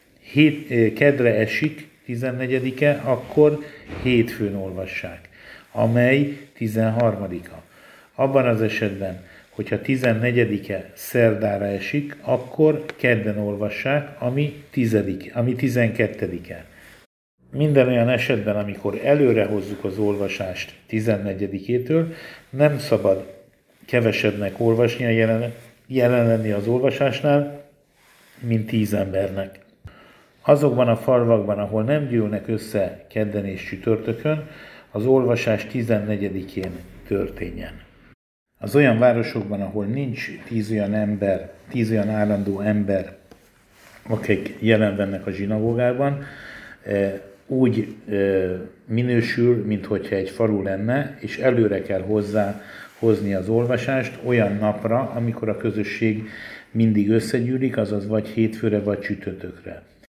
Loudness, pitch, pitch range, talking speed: -22 LUFS, 110 Hz, 100-125 Hz, 100 wpm